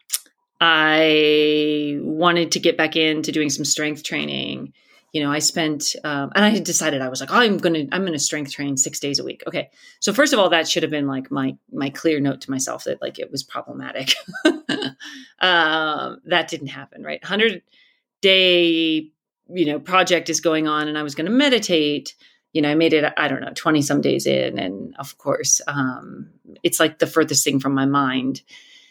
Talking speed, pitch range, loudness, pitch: 195 wpm, 145-180 Hz, -19 LUFS, 155 Hz